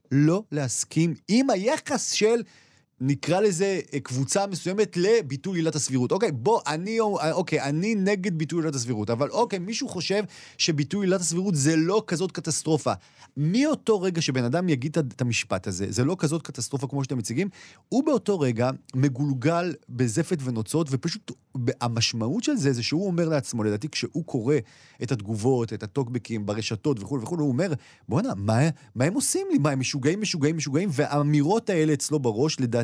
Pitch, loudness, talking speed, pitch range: 150 Hz, -25 LUFS, 150 wpm, 130-180 Hz